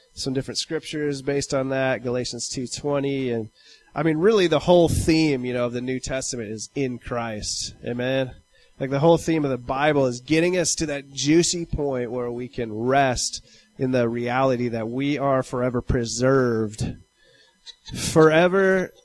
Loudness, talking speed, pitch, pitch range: -23 LUFS, 165 wpm, 135 Hz, 120-145 Hz